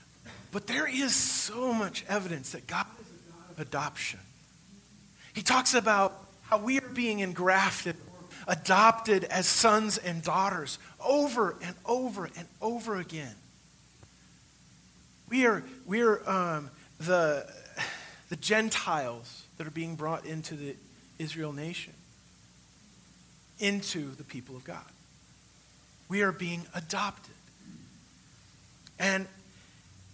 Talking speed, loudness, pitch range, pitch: 115 wpm, -29 LUFS, 160-215 Hz, 185 Hz